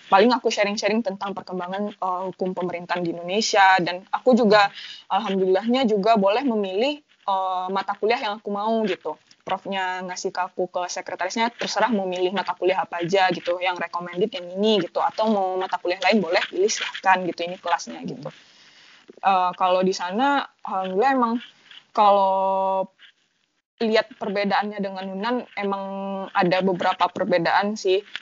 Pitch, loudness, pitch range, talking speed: 190 Hz, -23 LUFS, 185-210 Hz, 150 wpm